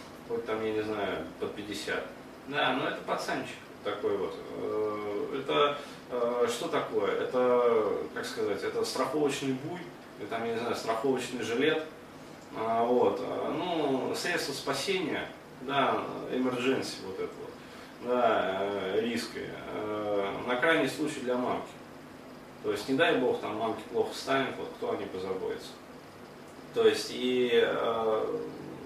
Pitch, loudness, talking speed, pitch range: 125 Hz, -31 LUFS, 130 wpm, 115-165 Hz